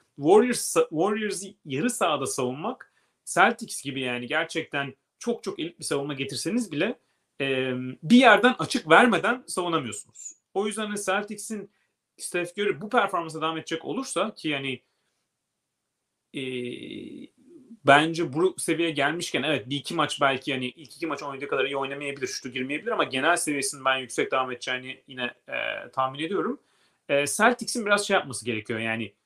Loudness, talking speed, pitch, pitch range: -26 LUFS, 145 wpm, 155 Hz, 135-205 Hz